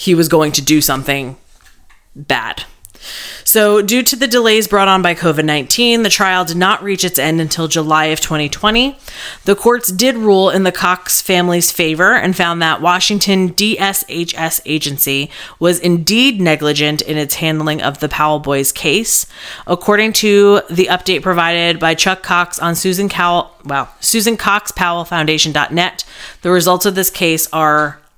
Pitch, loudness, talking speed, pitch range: 175 Hz, -12 LUFS, 160 wpm, 155-200 Hz